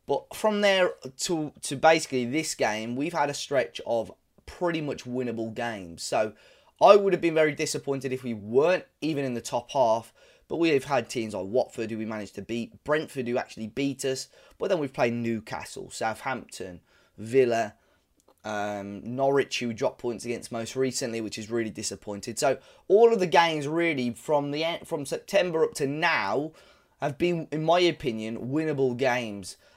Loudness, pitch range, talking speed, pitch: -27 LUFS, 115-155 Hz, 180 wpm, 130 Hz